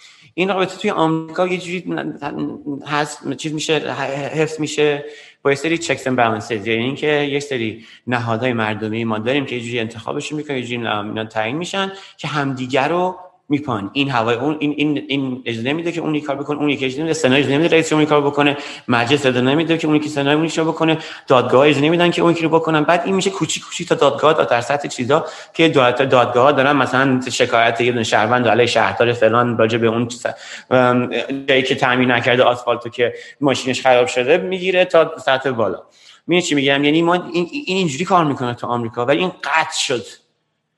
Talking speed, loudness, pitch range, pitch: 190 wpm, -17 LUFS, 125-160 Hz, 145 Hz